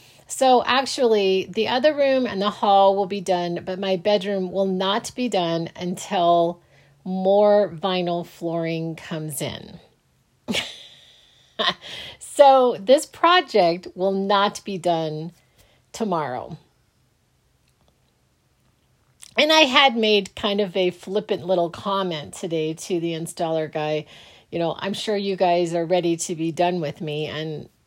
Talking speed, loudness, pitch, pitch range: 130 wpm, -21 LUFS, 185 Hz, 165-205 Hz